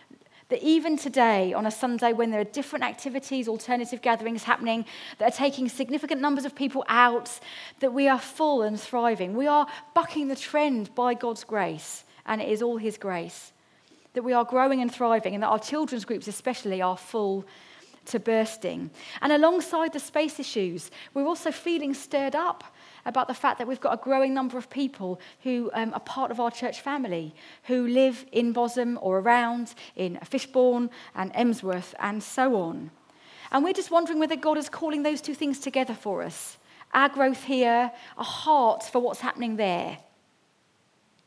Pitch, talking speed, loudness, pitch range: 250 Hz, 180 wpm, -26 LUFS, 225-280 Hz